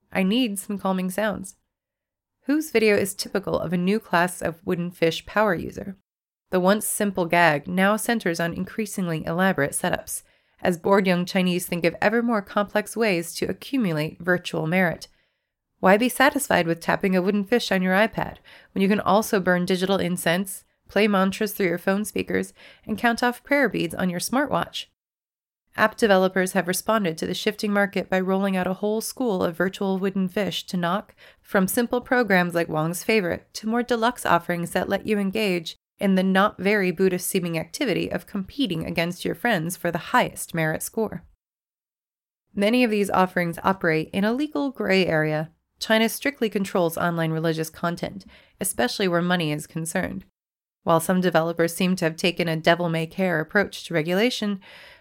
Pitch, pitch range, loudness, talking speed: 190 Hz, 175-215 Hz, -23 LUFS, 170 wpm